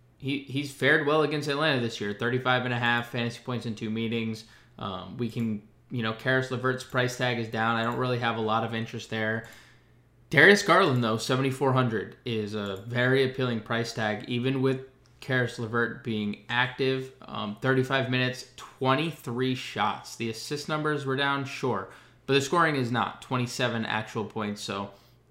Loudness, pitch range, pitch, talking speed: -27 LUFS, 115-130 Hz, 125 Hz, 175 wpm